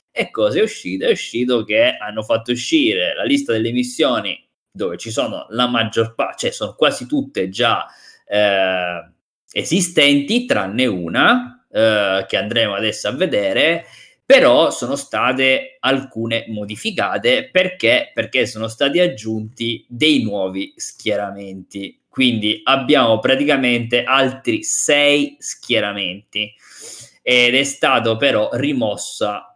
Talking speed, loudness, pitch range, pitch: 120 wpm, -17 LUFS, 110-180 Hz, 125 Hz